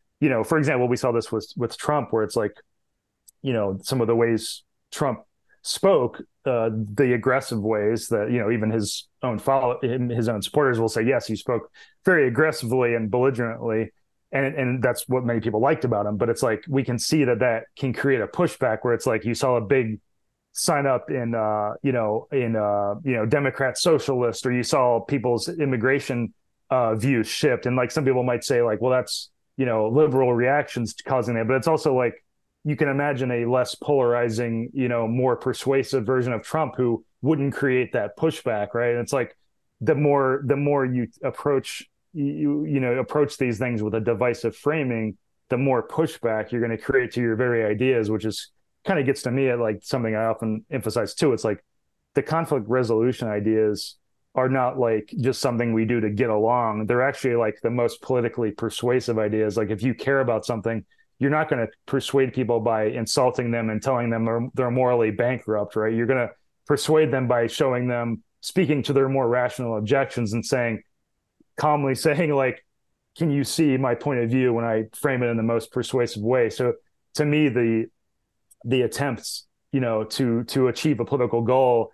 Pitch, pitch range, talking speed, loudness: 125 Hz, 115-135 Hz, 200 wpm, -23 LUFS